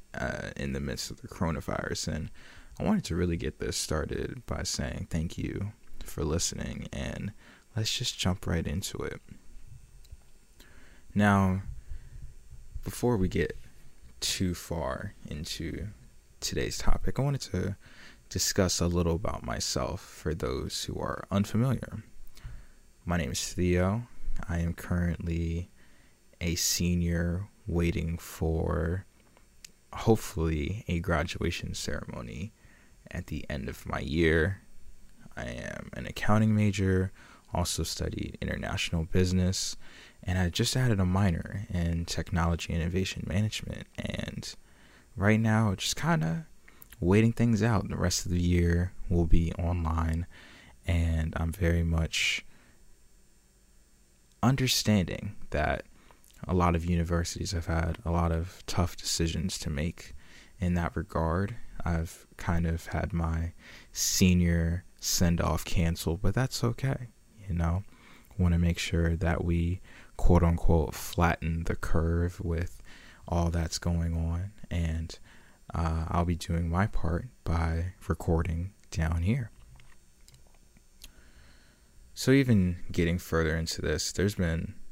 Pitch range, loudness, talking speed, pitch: 80-100 Hz, -30 LUFS, 125 wpm, 85 Hz